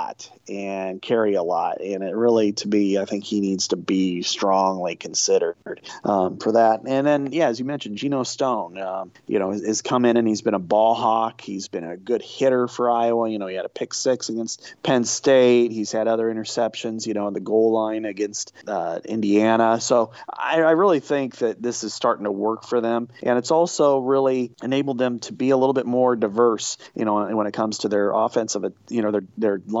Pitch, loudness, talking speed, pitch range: 115 Hz, -22 LUFS, 220 wpm, 105-125 Hz